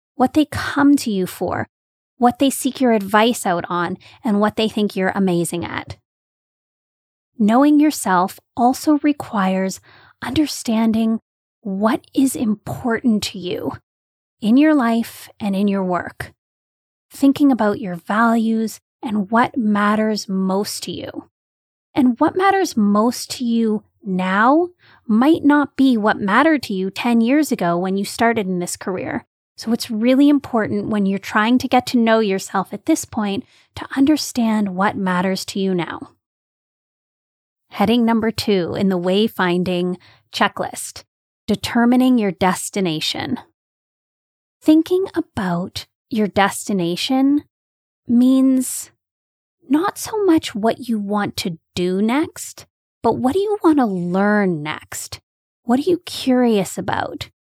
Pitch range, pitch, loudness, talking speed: 195-265 Hz, 225 Hz, -18 LUFS, 135 wpm